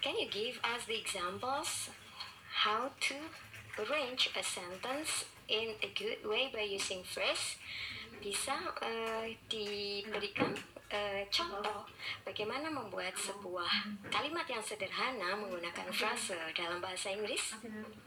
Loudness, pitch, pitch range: -37 LUFS, 210 Hz, 195-225 Hz